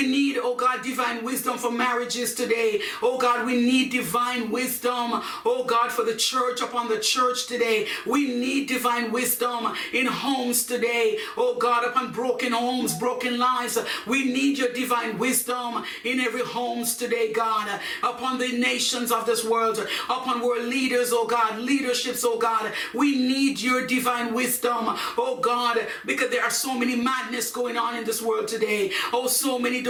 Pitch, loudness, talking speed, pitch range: 245 Hz, -24 LUFS, 170 wpm, 235-255 Hz